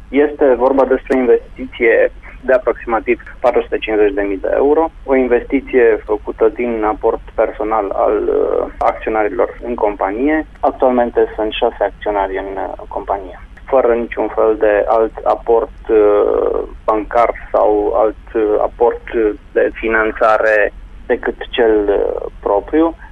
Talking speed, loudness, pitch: 105 wpm, -15 LUFS, 150 Hz